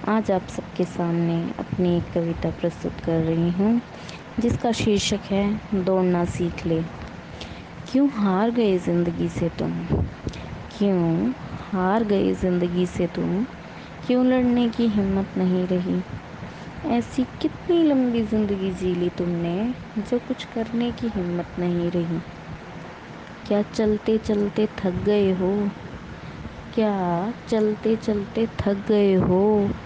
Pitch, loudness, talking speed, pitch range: 200 Hz, -23 LUFS, 125 wpm, 175-220 Hz